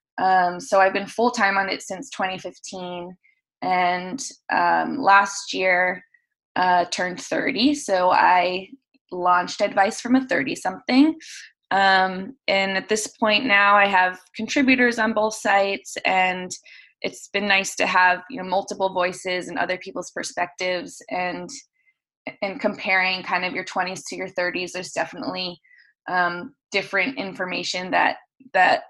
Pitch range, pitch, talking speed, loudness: 180-220 Hz, 190 Hz, 140 wpm, -21 LUFS